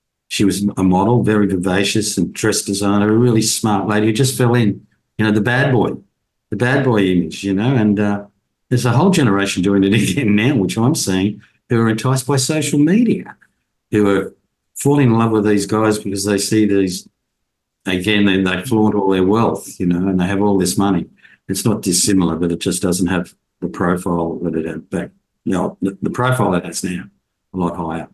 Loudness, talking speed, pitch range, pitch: -16 LUFS, 210 wpm, 95-110 Hz, 100 Hz